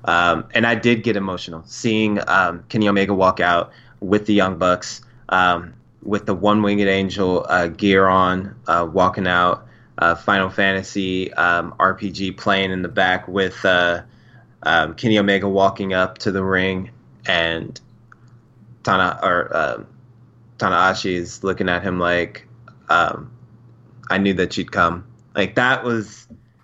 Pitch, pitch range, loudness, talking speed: 100 Hz, 95-115 Hz, -19 LUFS, 150 wpm